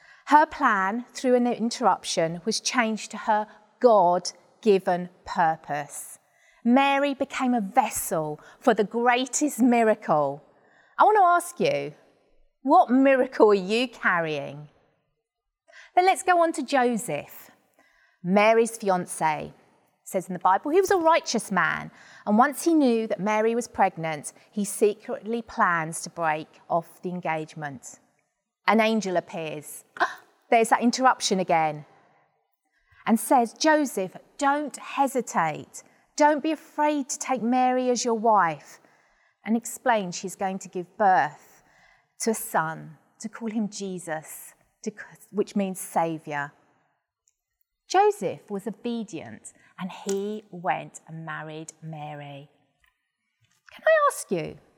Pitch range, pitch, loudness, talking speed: 170-255 Hz, 215 Hz, -24 LUFS, 125 wpm